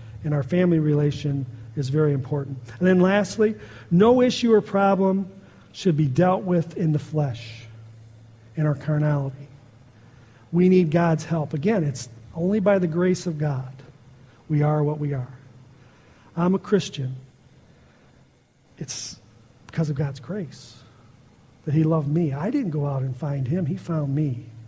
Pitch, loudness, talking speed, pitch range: 150 Hz, -23 LUFS, 155 wpm, 130-175 Hz